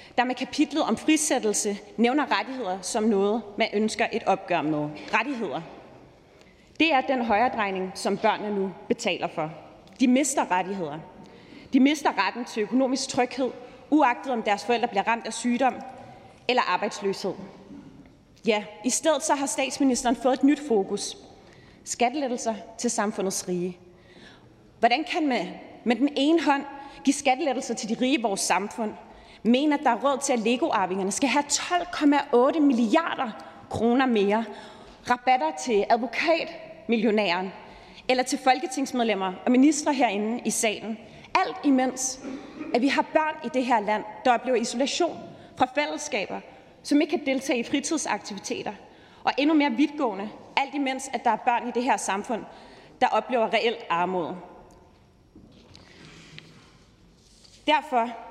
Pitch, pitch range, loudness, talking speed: 240 Hz, 210-275 Hz, -25 LUFS, 140 wpm